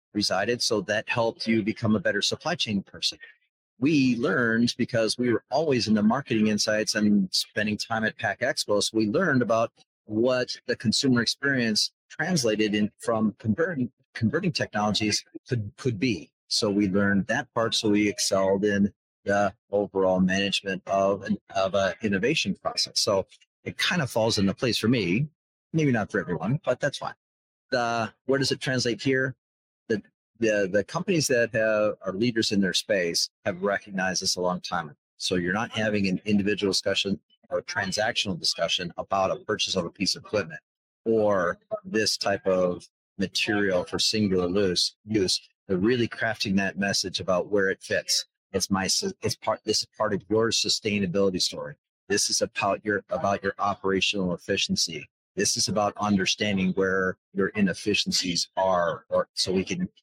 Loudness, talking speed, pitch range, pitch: -25 LUFS, 165 wpm, 100-115 Hz, 105 Hz